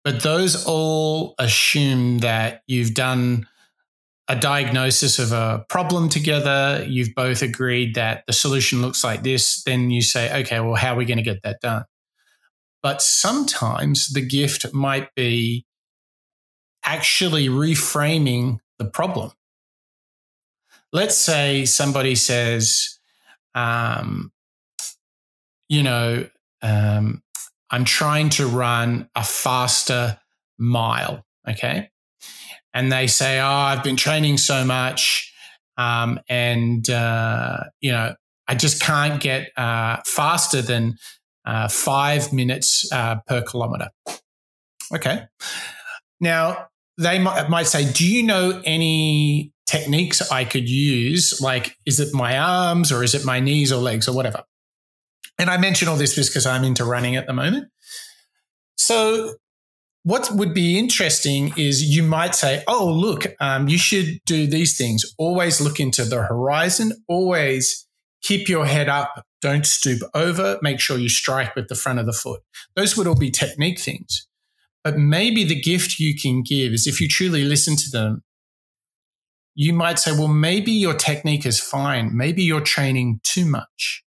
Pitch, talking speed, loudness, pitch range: 140 Hz, 145 wpm, -19 LUFS, 125-160 Hz